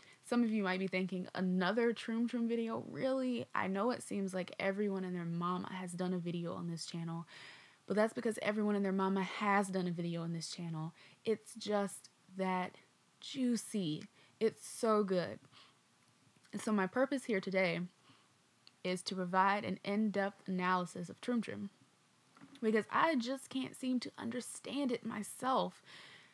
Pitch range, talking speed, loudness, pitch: 185-230 Hz, 165 wpm, -37 LUFS, 195 Hz